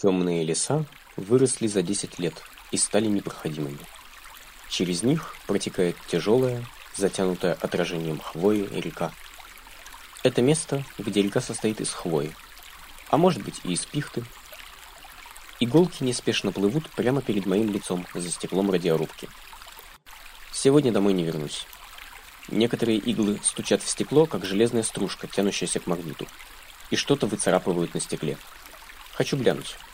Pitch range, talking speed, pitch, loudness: 90-120 Hz, 125 wpm, 100 Hz, -25 LUFS